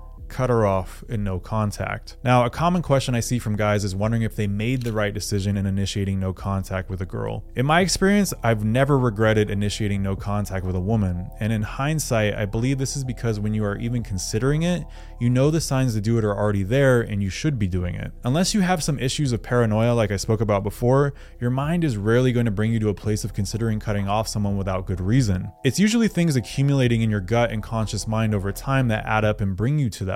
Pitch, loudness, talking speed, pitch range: 110 Hz, -23 LUFS, 245 wpm, 100-130 Hz